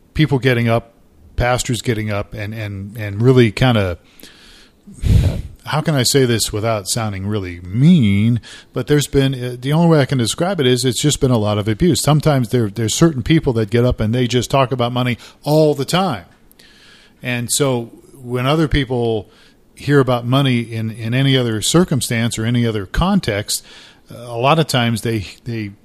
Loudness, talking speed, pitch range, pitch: -17 LUFS, 185 wpm, 110-140 Hz, 125 Hz